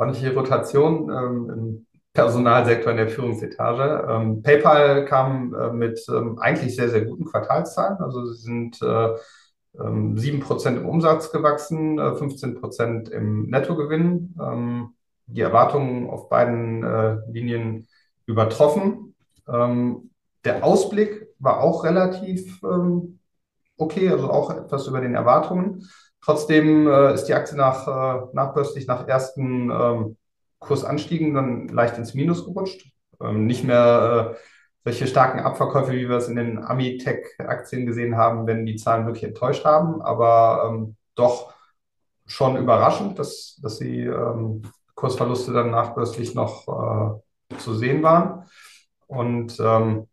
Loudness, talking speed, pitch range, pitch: -21 LUFS, 120 wpm, 115-150 Hz, 125 Hz